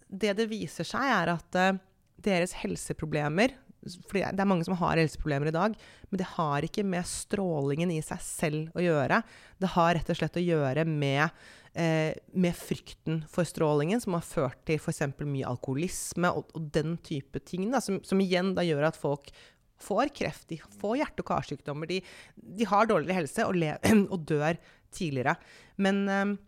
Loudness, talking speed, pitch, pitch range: -30 LUFS, 185 wpm, 170 Hz, 155-190 Hz